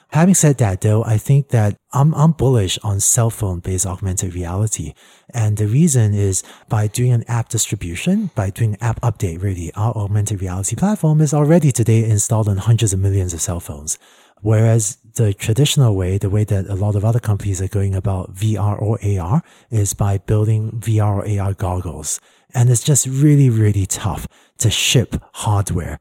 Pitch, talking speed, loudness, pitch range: 110 Hz, 185 wpm, -17 LUFS, 100-120 Hz